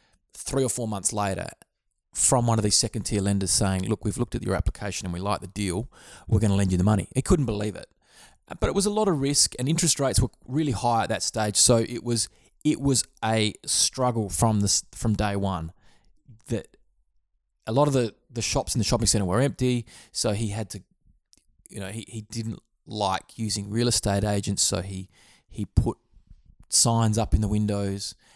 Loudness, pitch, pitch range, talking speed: -25 LUFS, 110 Hz, 100-120 Hz, 210 wpm